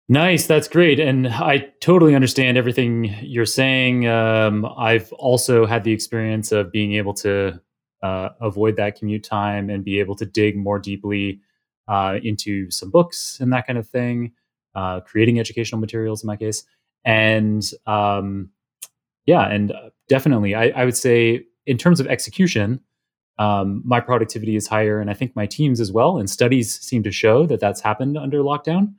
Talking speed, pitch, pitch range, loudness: 170 wpm, 110 Hz, 105-125 Hz, -19 LUFS